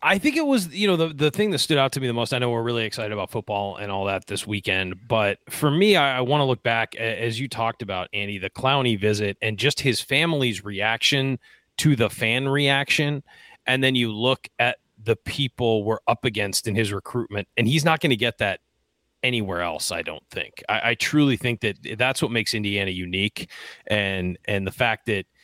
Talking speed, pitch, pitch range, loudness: 220 wpm, 115 Hz, 105-135 Hz, -23 LUFS